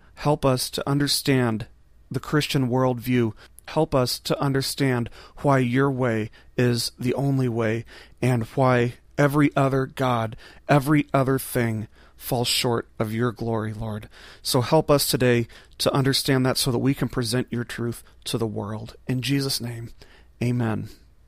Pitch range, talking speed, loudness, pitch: 115-135 Hz, 150 wpm, -23 LUFS, 125 Hz